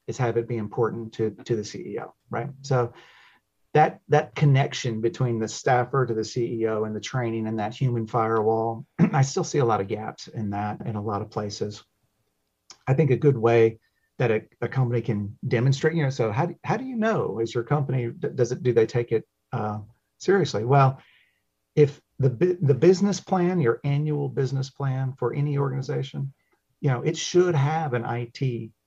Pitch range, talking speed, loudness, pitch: 115-145 Hz, 190 wpm, -25 LUFS, 125 Hz